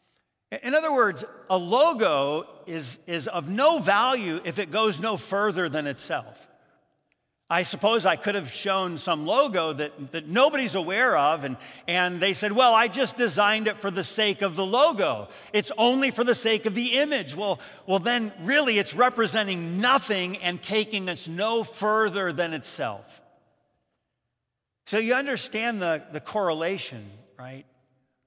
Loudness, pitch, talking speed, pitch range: -24 LUFS, 200 Hz, 155 wpm, 170-225 Hz